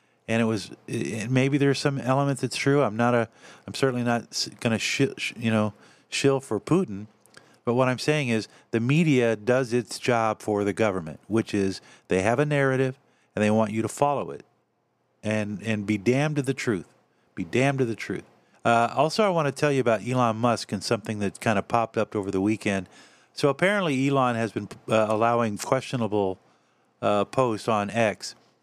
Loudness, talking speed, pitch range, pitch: -25 LUFS, 195 wpm, 105-135 Hz, 115 Hz